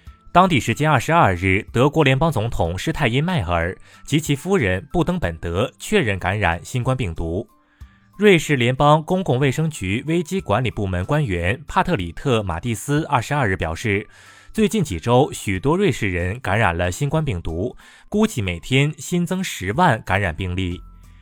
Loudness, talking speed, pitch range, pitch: -20 LUFS, 265 characters per minute, 95-155 Hz, 120 Hz